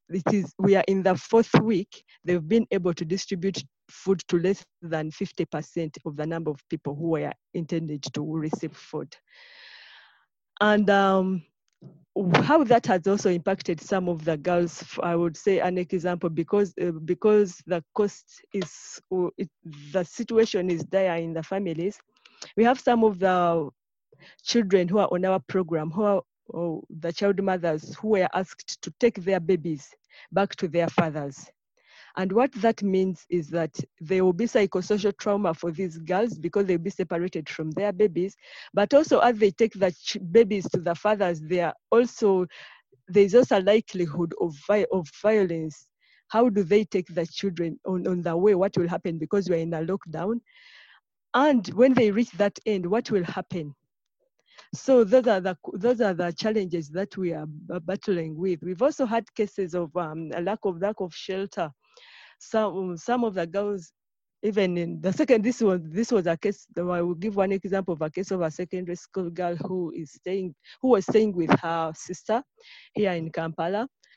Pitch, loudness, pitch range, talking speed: 185 Hz, -25 LUFS, 170-205 Hz, 180 wpm